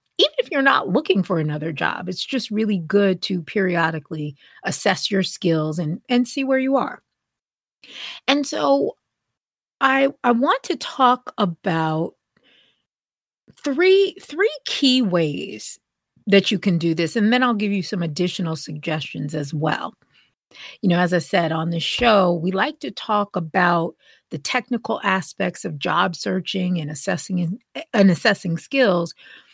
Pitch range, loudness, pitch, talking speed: 170-250 Hz, -20 LUFS, 190 Hz, 150 wpm